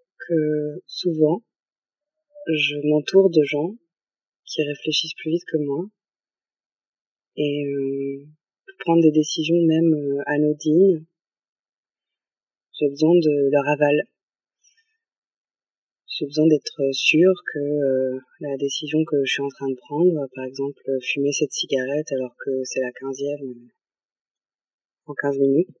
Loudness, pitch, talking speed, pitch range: -22 LUFS, 150 Hz, 125 wpm, 140-160 Hz